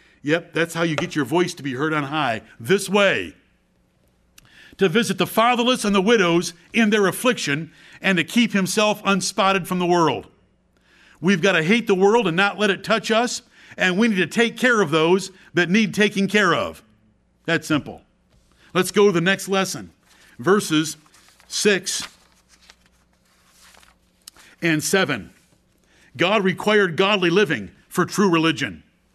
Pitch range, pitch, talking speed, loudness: 160-205 Hz, 185 Hz, 155 wpm, -20 LUFS